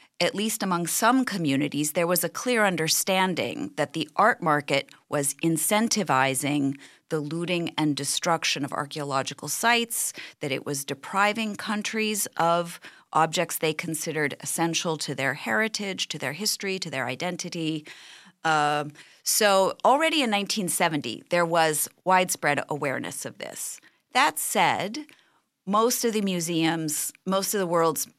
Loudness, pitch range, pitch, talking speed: -25 LUFS, 150-200 Hz, 170 Hz, 135 wpm